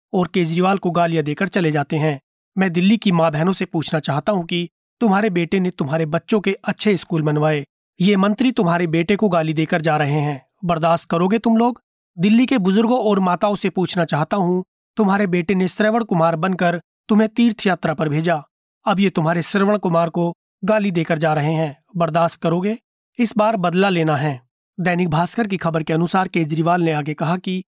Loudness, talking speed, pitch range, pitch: -19 LUFS, 195 wpm, 165-200 Hz, 180 Hz